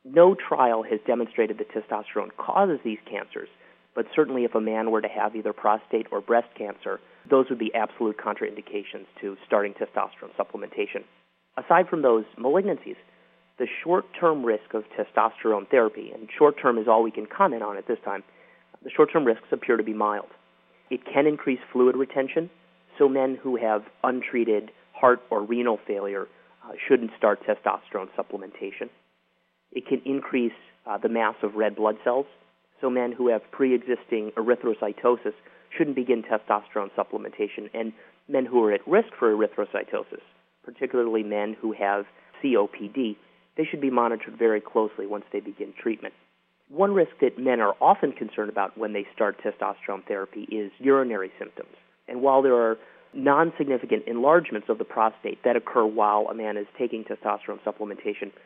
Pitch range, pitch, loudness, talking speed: 110-155 Hz, 125 Hz, -25 LUFS, 165 wpm